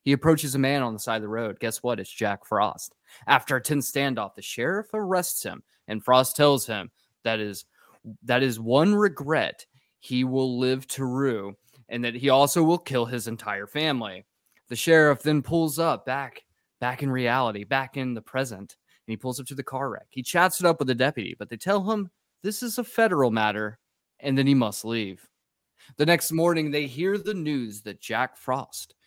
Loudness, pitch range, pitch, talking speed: -25 LUFS, 115-155 Hz, 130 Hz, 205 wpm